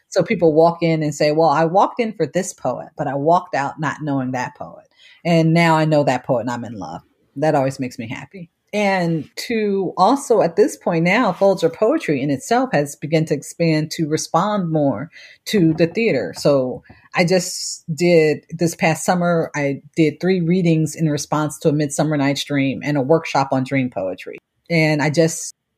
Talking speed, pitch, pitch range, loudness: 195 wpm, 160 Hz, 145-175 Hz, -18 LUFS